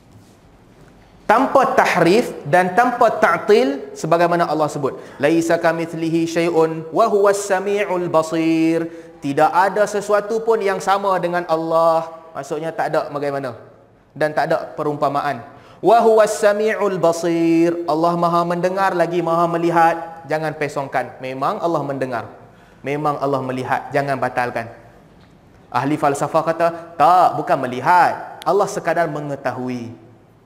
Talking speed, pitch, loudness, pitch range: 120 wpm, 165 Hz, -18 LUFS, 145-175 Hz